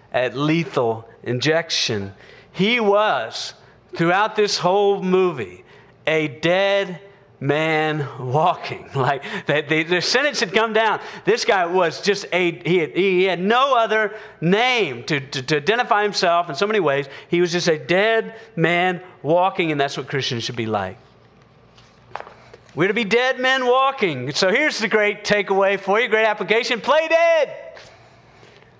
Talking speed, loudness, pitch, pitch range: 150 wpm, -19 LUFS, 185 Hz, 155-215 Hz